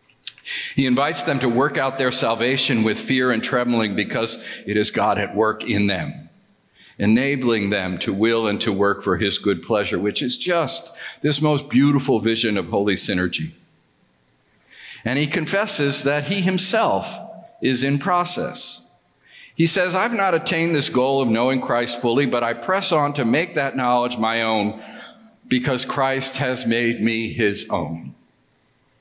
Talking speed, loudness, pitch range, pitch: 160 wpm, -19 LUFS, 110-150 Hz, 125 Hz